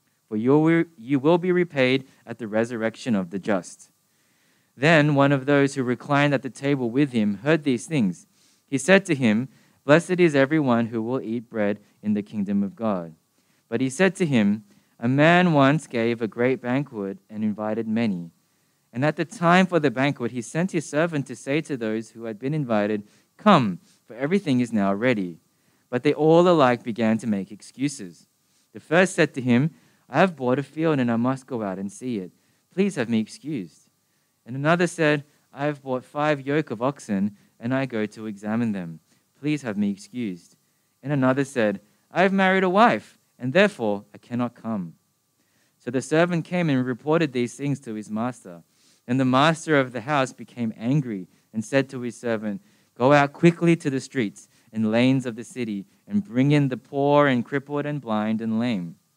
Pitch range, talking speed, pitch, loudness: 115-150 Hz, 195 wpm, 130 Hz, -23 LUFS